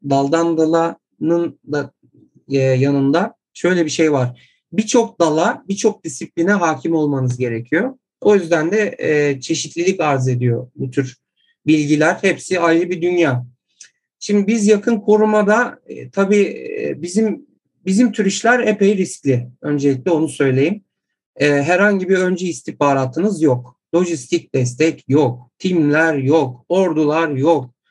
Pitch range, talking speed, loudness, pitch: 140-195 Hz, 115 wpm, -17 LUFS, 165 Hz